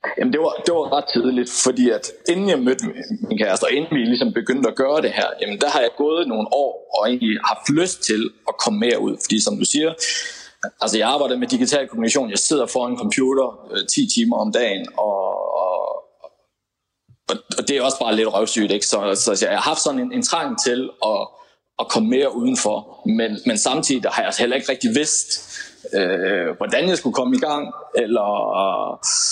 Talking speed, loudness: 205 wpm, -19 LUFS